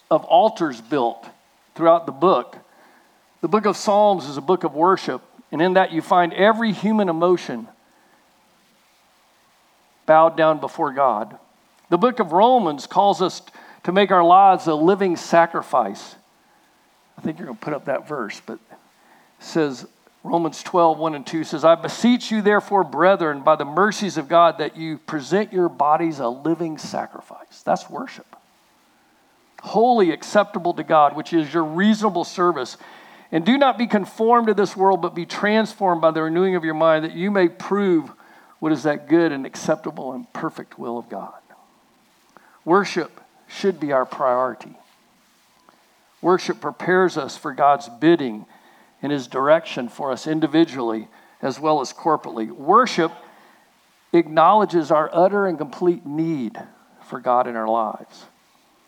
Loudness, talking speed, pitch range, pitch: -19 LUFS, 155 wpm, 155-195 Hz, 170 Hz